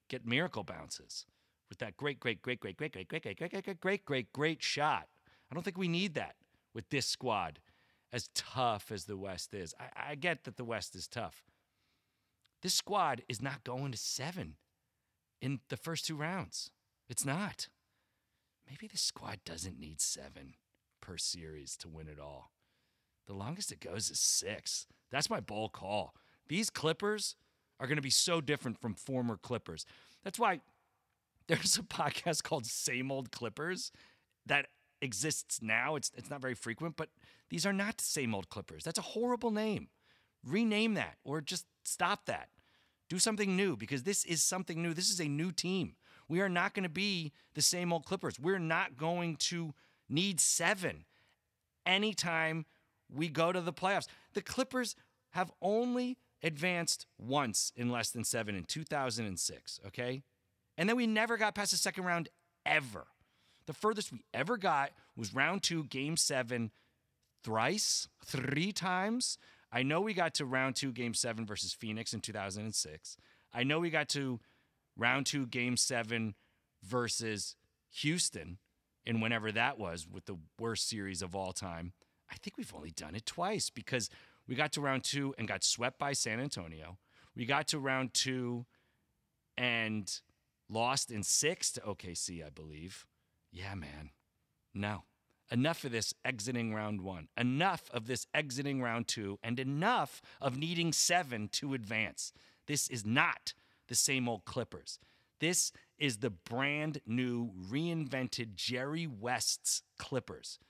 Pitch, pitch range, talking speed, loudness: 130 Hz, 110-165 Hz, 160 wpm, -35 LUFS